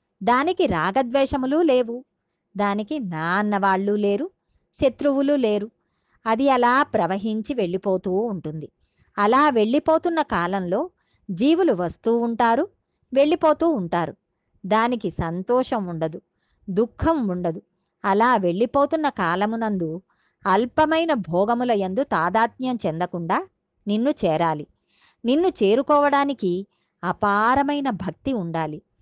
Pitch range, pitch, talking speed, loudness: 190-275 Hz, 225 Hz, 85 wpm, -22 LUFS